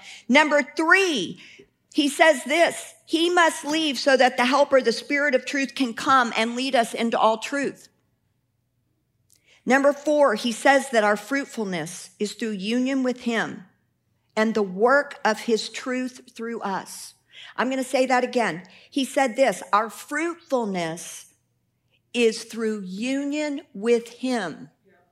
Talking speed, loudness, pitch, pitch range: 145 wpm, -22 LUFS, 250 Hz, 220-280 Hz